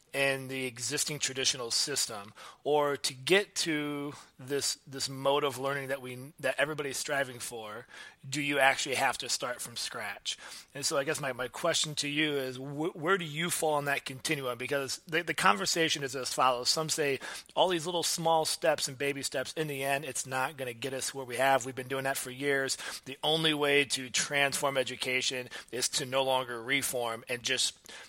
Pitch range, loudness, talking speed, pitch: 130-150 Hz, -31 LUFS, 200 wpm, 140 Hz